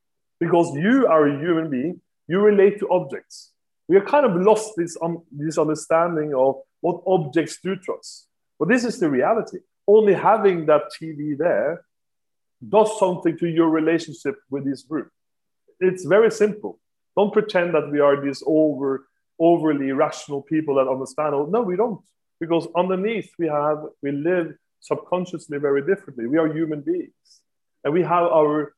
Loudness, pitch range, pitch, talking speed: -21 LUFS, 150-190 Hz, 165 Hz, 165 wpm